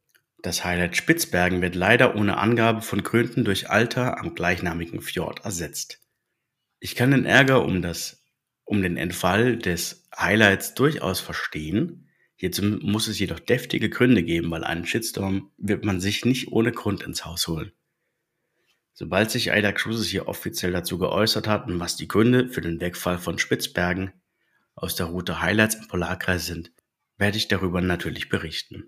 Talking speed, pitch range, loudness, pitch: 160 wpm, 90-110 Hz, -23 LUFS, 95 Hz